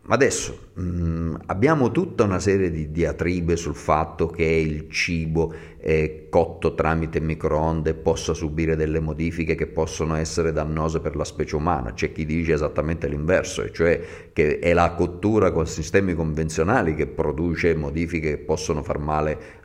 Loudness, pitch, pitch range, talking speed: -23 LUFS, 80 Hz, 80-85 Hz, 145 wpm